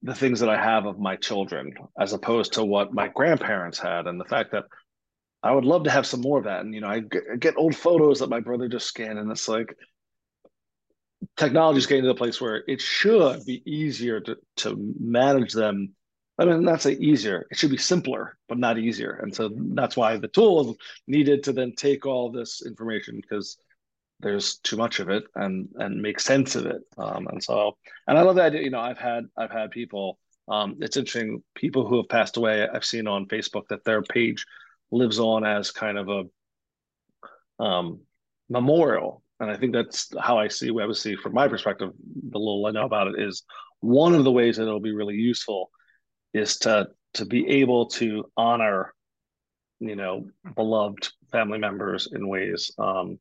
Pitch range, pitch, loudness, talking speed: 105-125 Hz, 115 Hz, -24 LUFS, 200 wpm